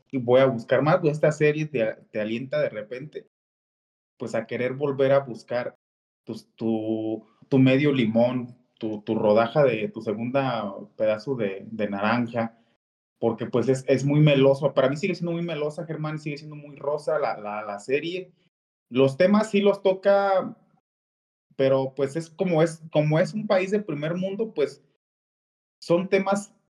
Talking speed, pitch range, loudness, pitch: 165 wpm, 115-170 Hz, -24 LUFS, 140 Hz